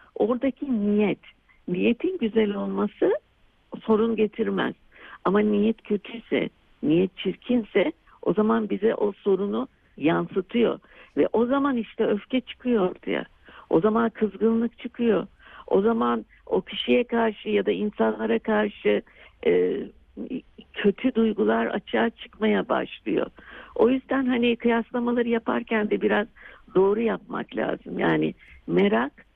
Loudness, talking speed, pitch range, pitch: -25 LUFS, 115 wpm, 210-240 Hz, 225 Hz